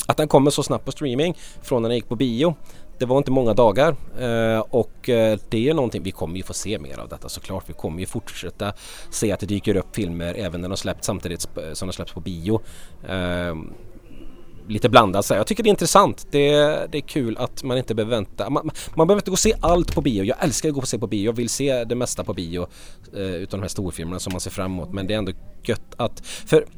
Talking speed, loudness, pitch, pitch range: 245 wpm, -22 LUFS, 110 Hz, 95-130 Hz